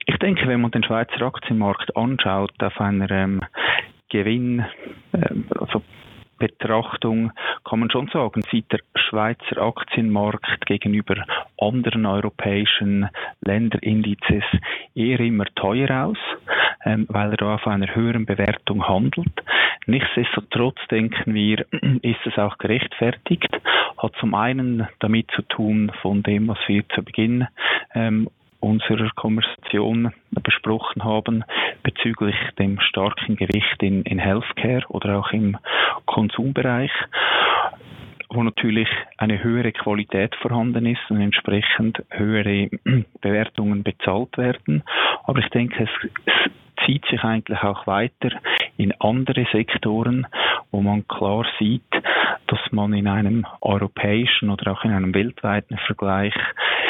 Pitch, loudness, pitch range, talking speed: 110 Hz, -21 LUFS, 100-115 Hz, 120 wpm